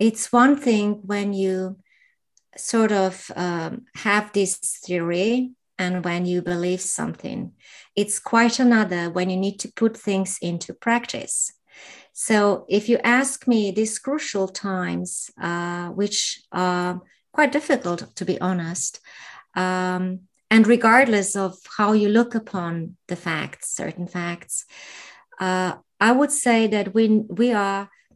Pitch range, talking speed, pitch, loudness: 180-225 Hz, 135 wpm, 200 Hz, -22 LUFS